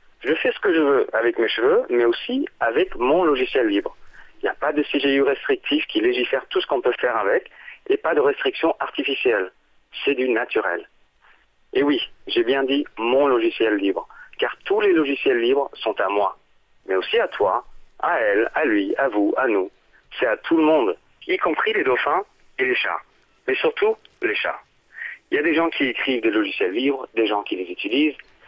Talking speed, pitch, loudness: 205 wpm, 375 Hz, -21 LUFS